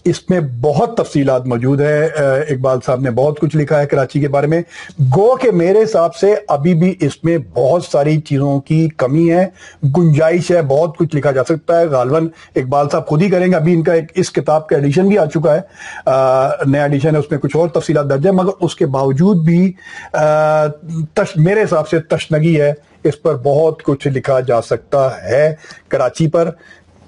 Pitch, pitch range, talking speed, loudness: 155 Hz, 145-170 Hz, 195 wpm, -14 LUFS